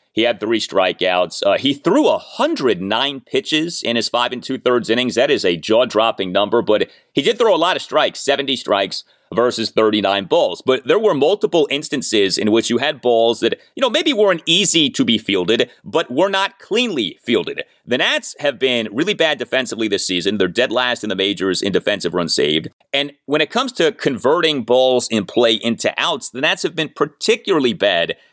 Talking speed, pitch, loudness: 200 wpm, 130 Hz, -17 LUFS